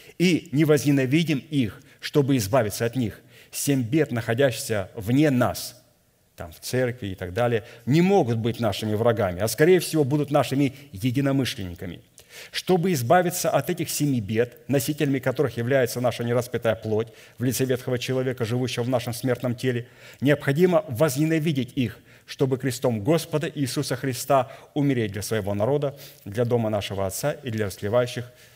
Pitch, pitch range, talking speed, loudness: 130 Hz, 115-145 Hz, 145 wpm, -24 LUFS